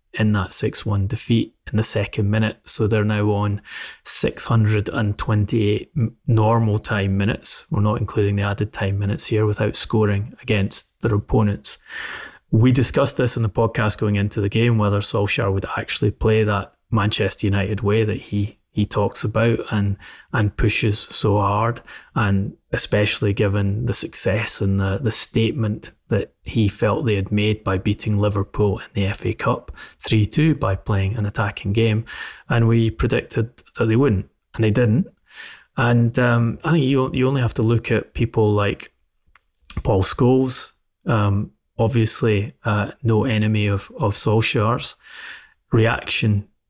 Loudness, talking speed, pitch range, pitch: -20 LUFS, 155 wpm, 100-115 Hz, 110 Hz